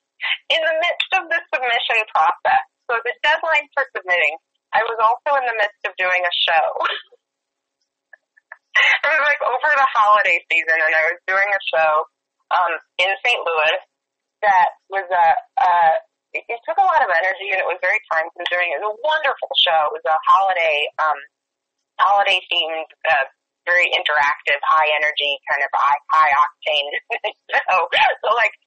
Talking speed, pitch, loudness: 165 wpm, 215 Hz, -17 LUFS